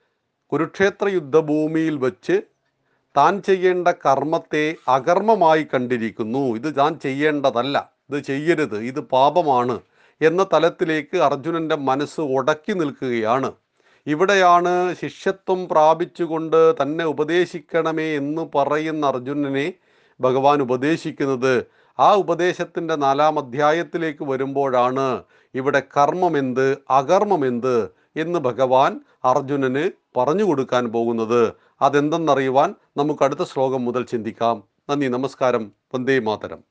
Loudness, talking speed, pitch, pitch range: -20 LUFS, 90 wpm, 145 Hz, 135-165 Hz